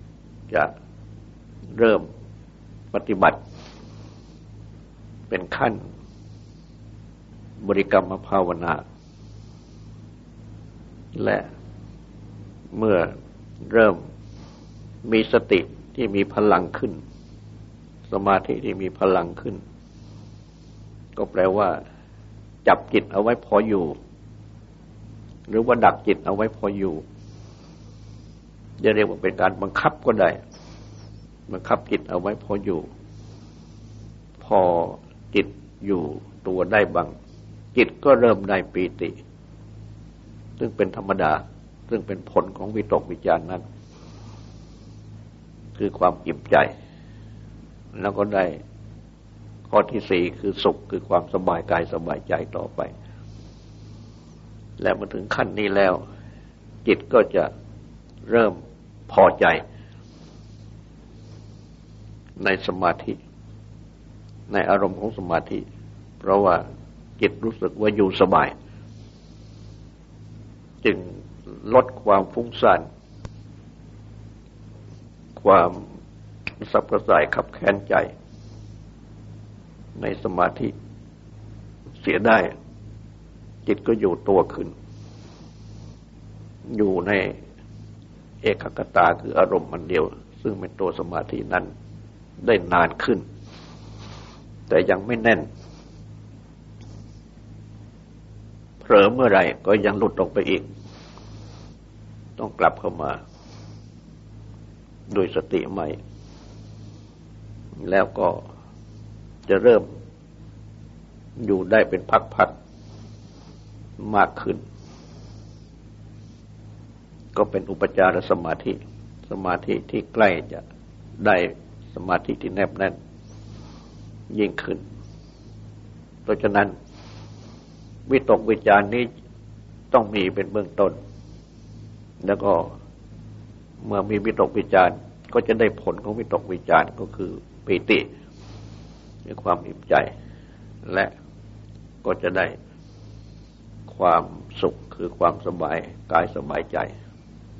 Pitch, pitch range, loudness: 105 Hz, 100-110 Hz, -22 LUFS